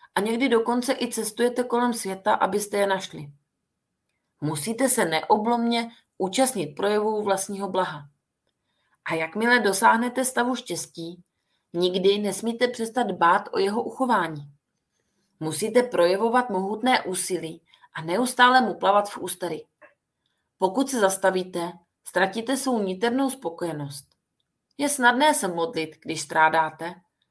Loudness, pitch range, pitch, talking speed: -23 LUFS, 170-240 Hz, 195 Hz, 115 wpm